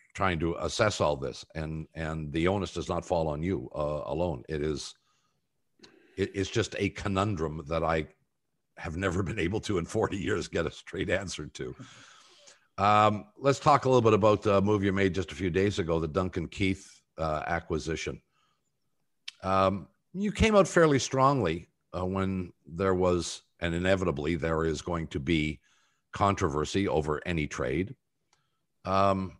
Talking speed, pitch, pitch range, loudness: 165 wpm, 95 Hz, 80-100 Hz, -29 LUFS